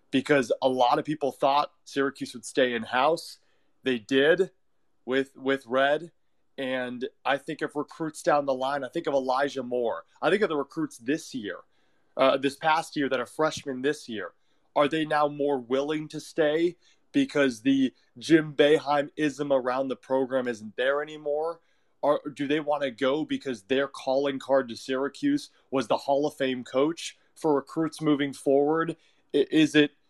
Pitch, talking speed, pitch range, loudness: 145 Hz, 175 wpm, 135-155 Hz, -27 LUFS